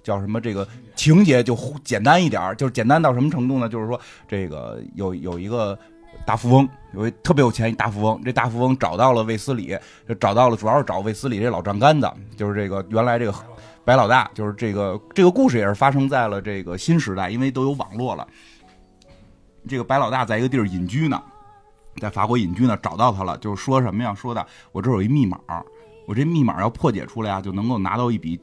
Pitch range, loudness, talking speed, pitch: 105-130 Hz, -20 LUFS, 335 characters per minute, 115 Hz